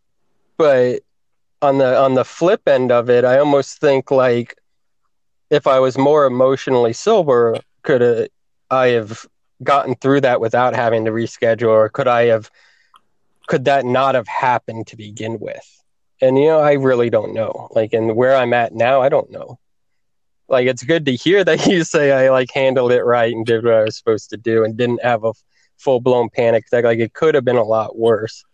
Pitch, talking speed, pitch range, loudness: 125 Hz, 200 wpm, 115-135 Hz, -15 LUFS